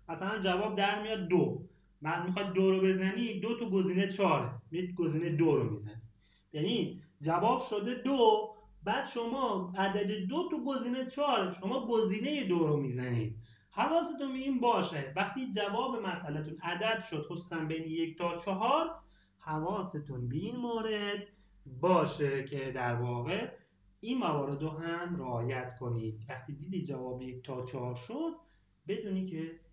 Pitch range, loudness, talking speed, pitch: 145-215 Hz, -34 LUFS, 145 wpm, 180 Hz